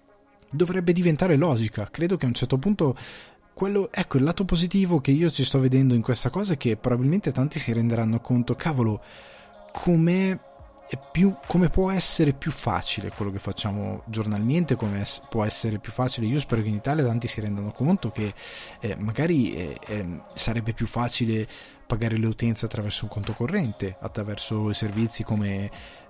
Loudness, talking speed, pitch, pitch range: -25 LUFS, 165 wpm, 120 Hz, 110-155 Hz